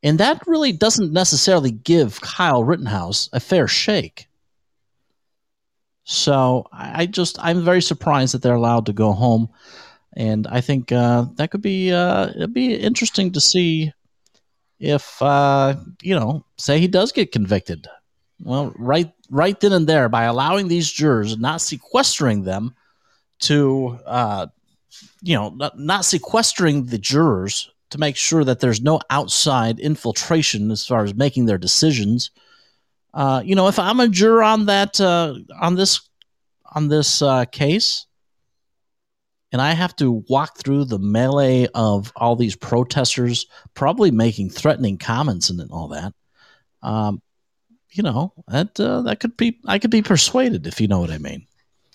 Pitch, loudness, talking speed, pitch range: 140 Hz, -18 LUFS, 155 wpm, 120-180 Hz